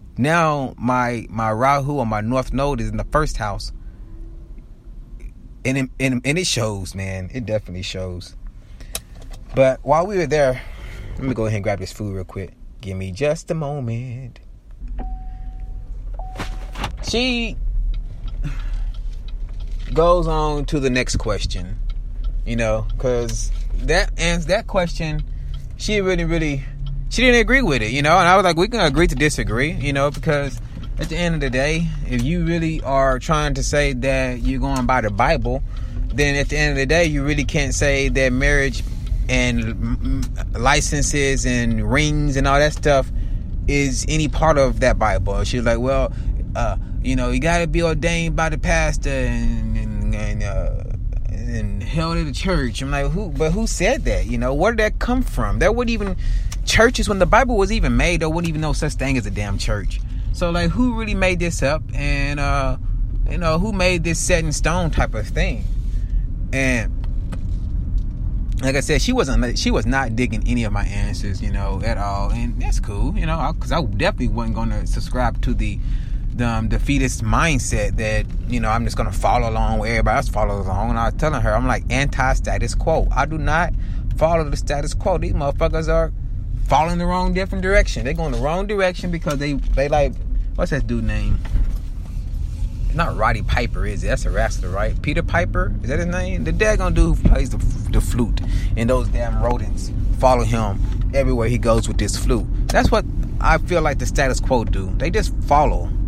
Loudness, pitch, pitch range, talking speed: -20 LUFS, 120 Hz, 105-145 Hz, 190 wpm